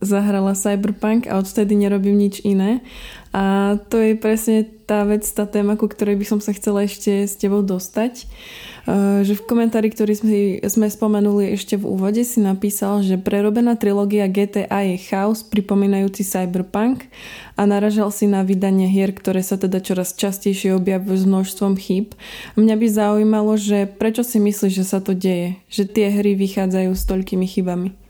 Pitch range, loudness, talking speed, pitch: 195-215 Hz, -18 LUFS, 170 wpm, 205 Hz